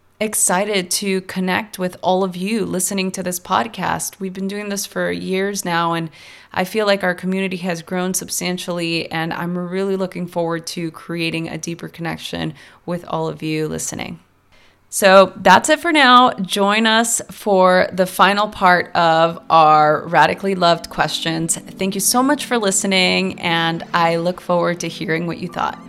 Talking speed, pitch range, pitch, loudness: 170 wpm, 165-195 Hz, 180 Hz, -17 LUFS